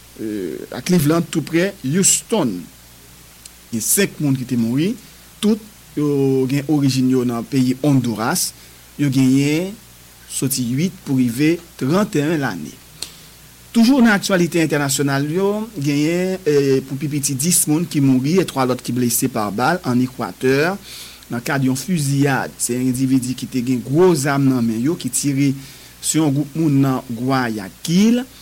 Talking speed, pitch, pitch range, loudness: 155 wpm, 140 Hz, 125-165 Hz, -18 LUFS